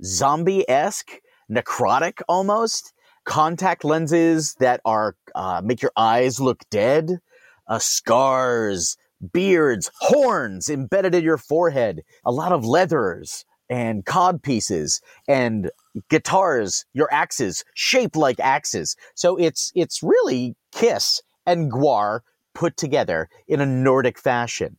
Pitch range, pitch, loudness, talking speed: 125-180 Hz, 155 Hz, -20 LUFS, 120 wpm